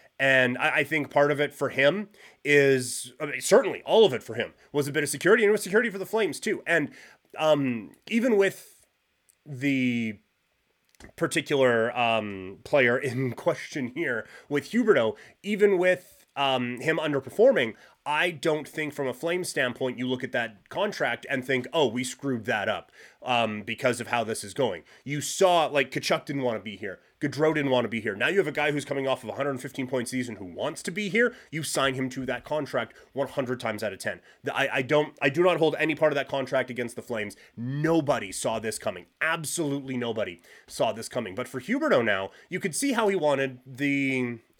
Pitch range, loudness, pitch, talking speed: 125-155 Hz, -26 LUFS, 140 Hz, 210 wpm